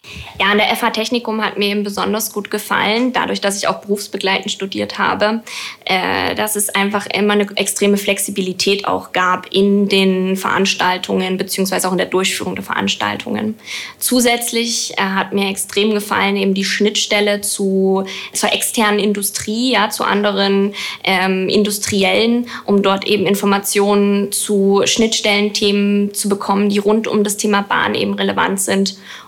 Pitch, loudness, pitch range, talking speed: 200 Hz, -16 LUFS, 195-210 Hz, 145 wpm